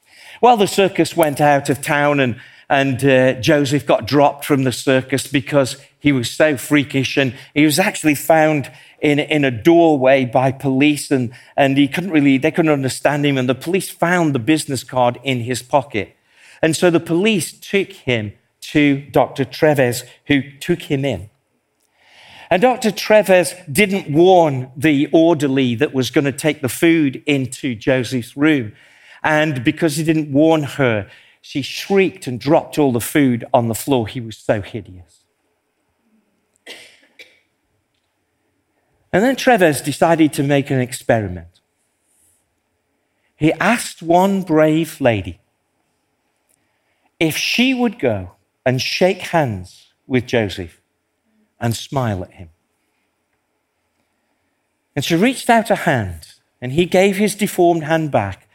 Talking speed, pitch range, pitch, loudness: 145 wpm, 130-165 Hz, 145 Hz, -16 LUFS